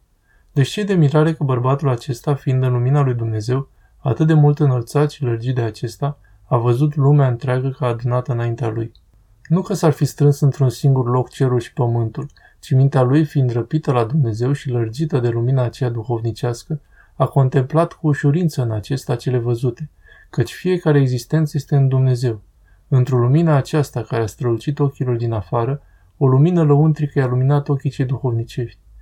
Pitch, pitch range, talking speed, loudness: 130 Hz, 120-145 Hz, 170 wpm, -18 LUFS